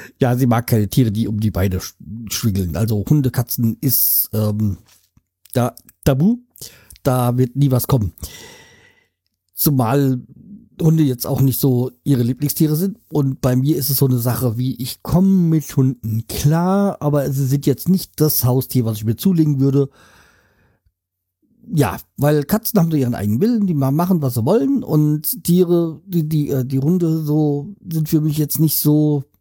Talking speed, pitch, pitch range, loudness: 170 wpm, 135 Hz, 115-155 Hz, -18 LUFS